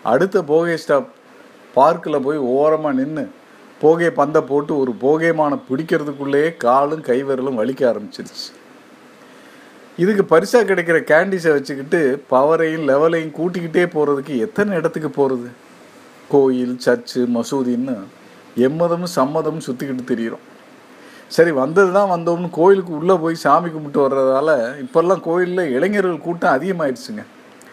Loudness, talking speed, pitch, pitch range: -17 LUFS, 110 wpm, 155 Hz, 135-170 Hz